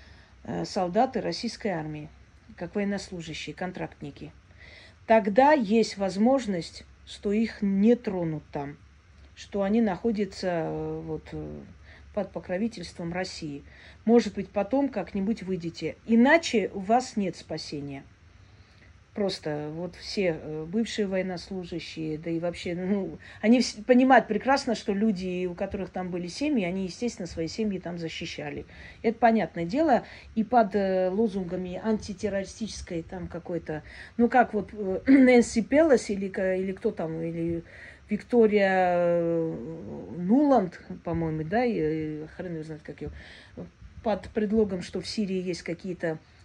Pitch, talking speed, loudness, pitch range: 185 Hz, 120 wpm, -27 LUFS, 165-220 Hz